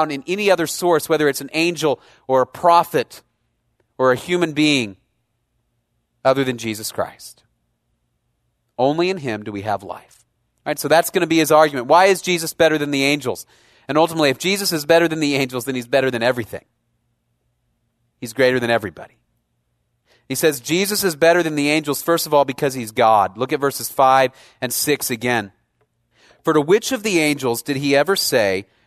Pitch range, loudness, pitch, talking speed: 120-160 Hz, -18 LUFS, 140 Hz, 190 wpm